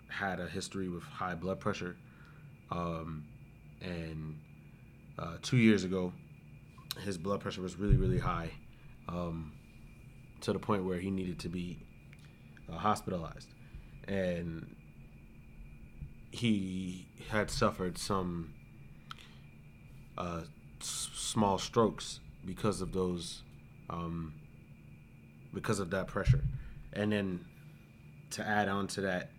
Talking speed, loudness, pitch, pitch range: 110 wpm, -36 LUFS, 90 Hz, 80-100 Hz